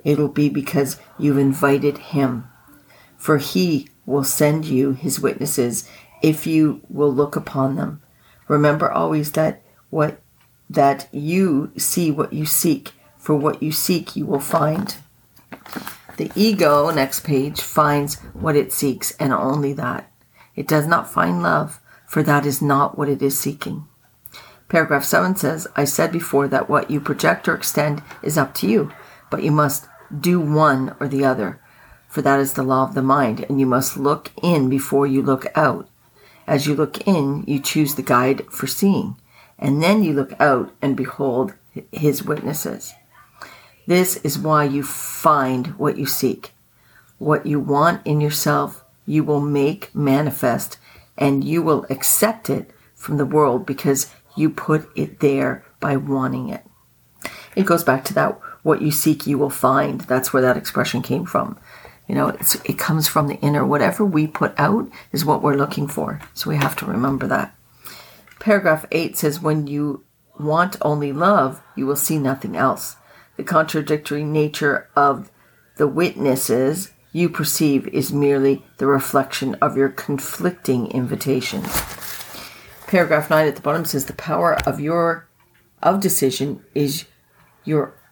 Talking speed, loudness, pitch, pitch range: 160 wpm, -19 LUFS, 145 Hz, 135-155 Hz